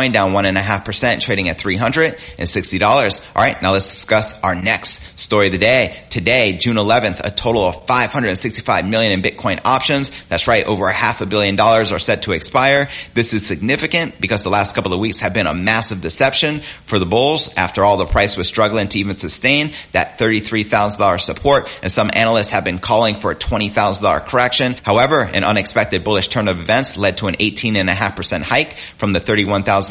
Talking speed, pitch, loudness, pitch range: 220 wpm, 105 Hz, -15 LUFS, 95-115 Hz